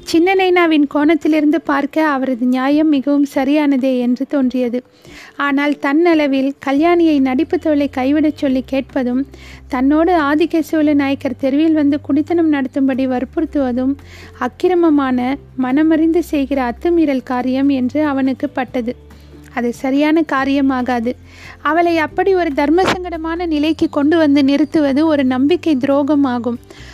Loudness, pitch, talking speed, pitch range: -15 LUFS, 285 Hz, 105 wpm, 265-315 Hz